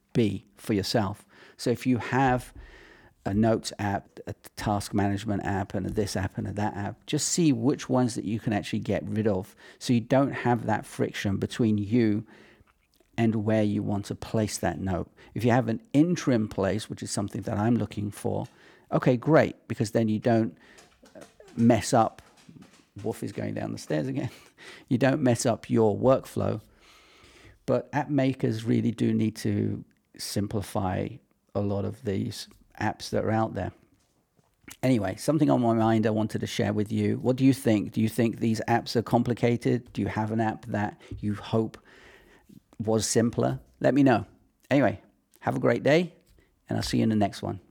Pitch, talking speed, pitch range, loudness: 110 Hz, 185 wpm, 105-120 Hz, -27 LUFS